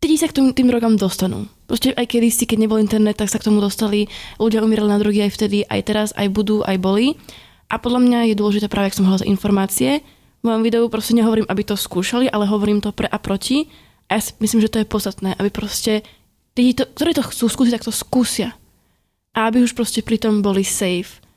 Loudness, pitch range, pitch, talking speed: -18 LUFS, 205-235 Hz, 215 Hz, 220 wpm